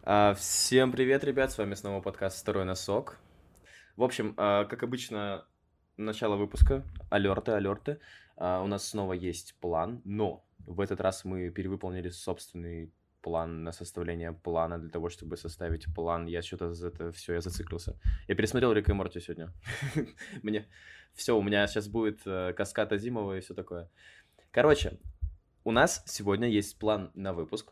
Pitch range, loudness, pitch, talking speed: 85-105 Hz, -32 LUFS, 95 Hz, 160 wpm